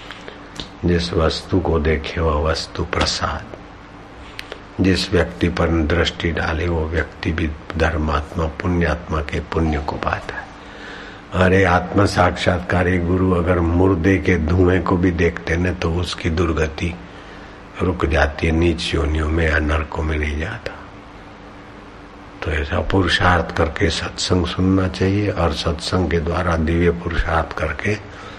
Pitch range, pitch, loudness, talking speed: 80-95 Hz, 90 Hz, -19 LUFS, 130 wpm